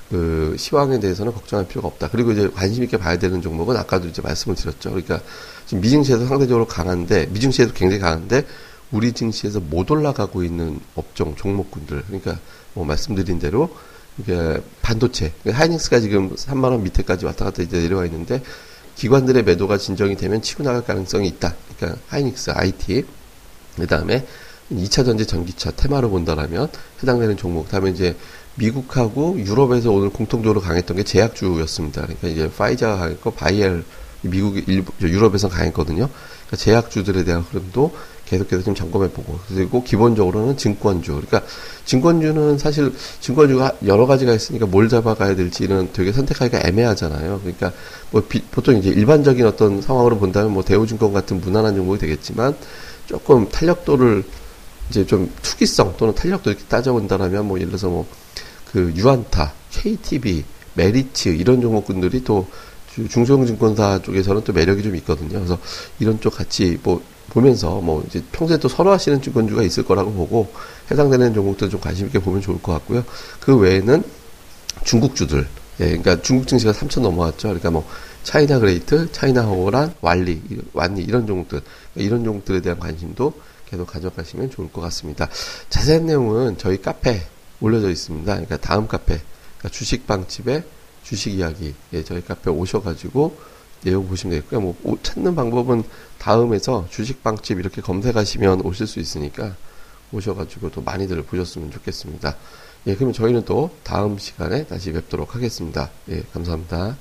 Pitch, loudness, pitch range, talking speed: 100 Hz, -19 LUFS, 90-120 Hz, 395 characters per minute